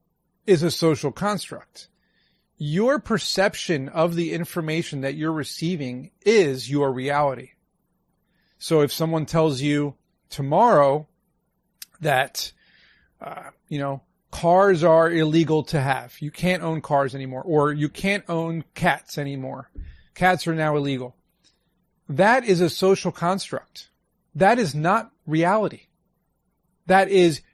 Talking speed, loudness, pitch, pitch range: 120 wpm, -22 LUFS, 165 Hz, 145-185 Hz